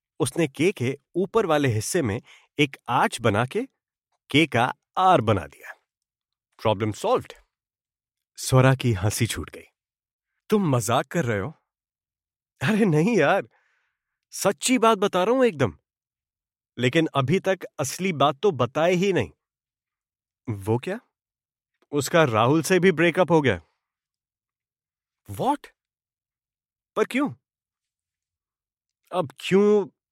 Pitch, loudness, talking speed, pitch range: 140 Hz, -23 LUFS, 120 wpm, 115-180 Hz